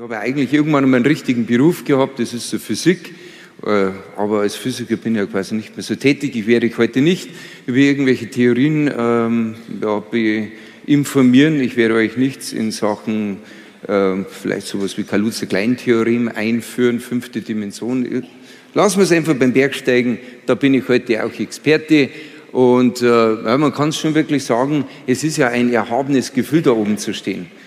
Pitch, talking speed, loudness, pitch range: 120 Hz, 170 wpm, -17 LUFS, 110-135 Hz